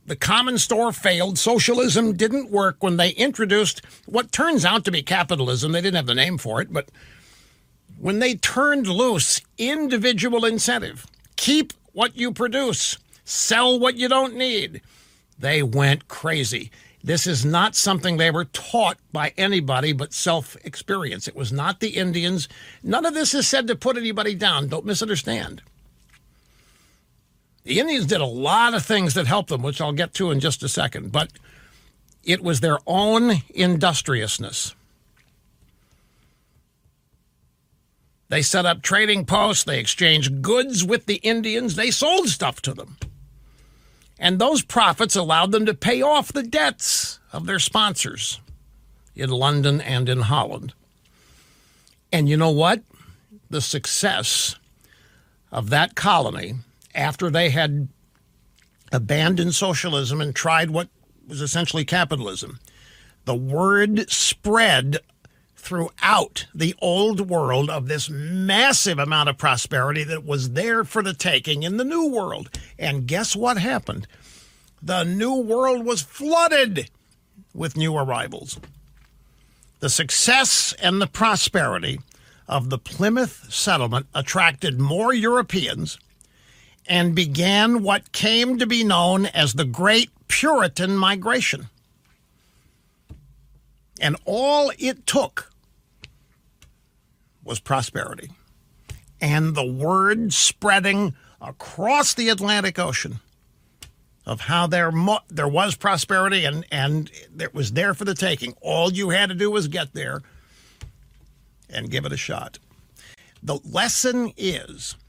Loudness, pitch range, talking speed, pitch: -20 LUFS, 140-215 Hz, 130 wpm, 175 Hz